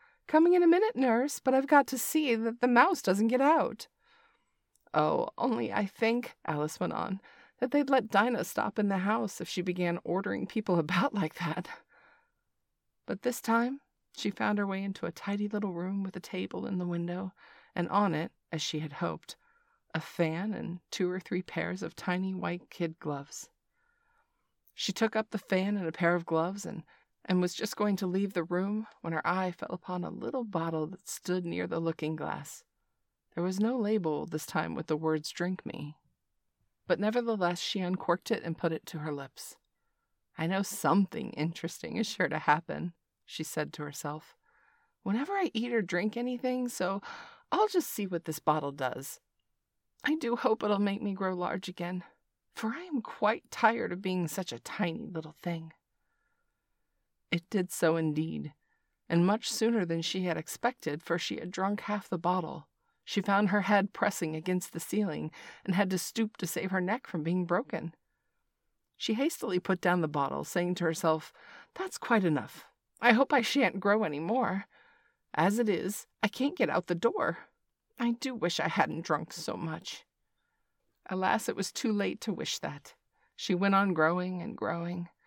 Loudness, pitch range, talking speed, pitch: -31 LUFS, 165-225 Hz, 185 wpm, 185 Hz